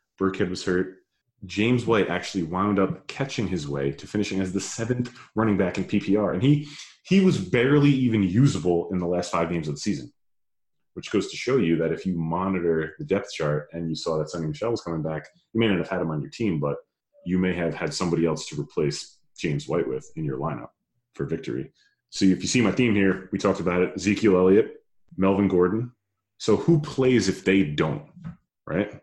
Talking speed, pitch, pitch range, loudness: 215 wpm, 95 Hz, 85-115 Hz, -24 LUFS